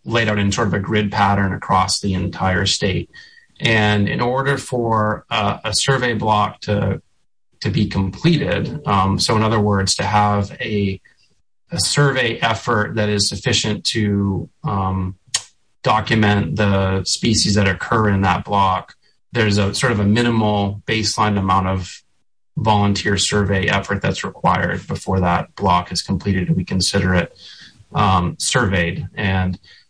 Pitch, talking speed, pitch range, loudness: 100 Hz, 150 wpm, 95-110 Hz, -18 LUFS